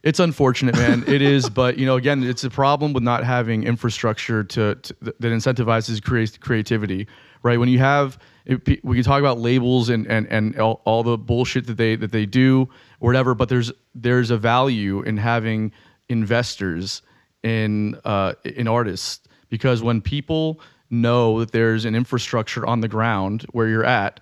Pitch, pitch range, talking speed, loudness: 120 Hz, 110-130 Hz, 170 wpm, -20 LUFS